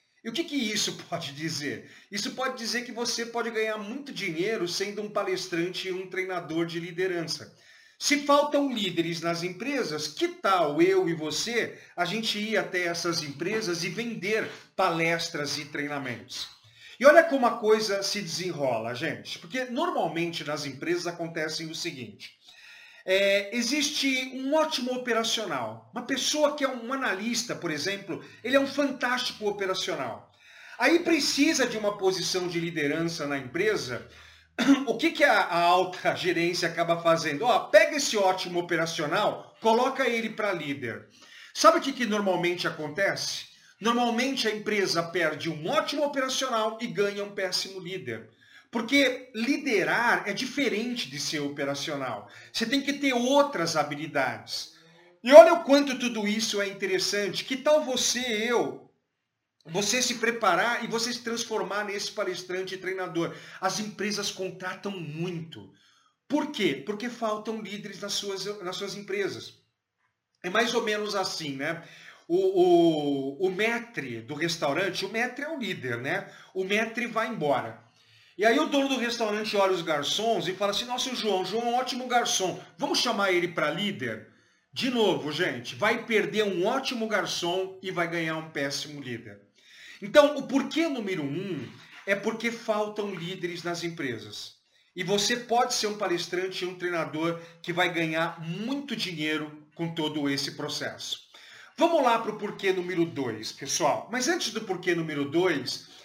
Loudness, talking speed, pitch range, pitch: -27 LUFS, 155 wpm, 170-240 Hz, 200 Hz